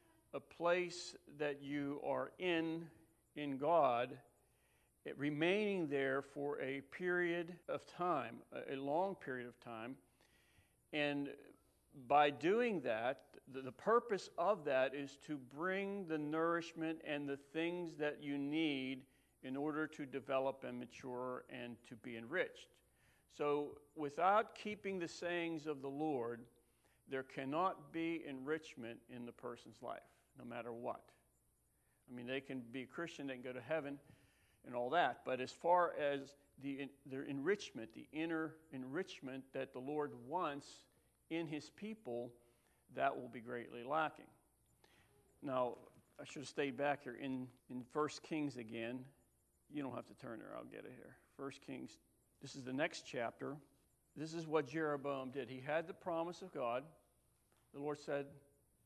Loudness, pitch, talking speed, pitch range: -42 LUFS, 140 Hz, 150 wpm, 130-160 Hz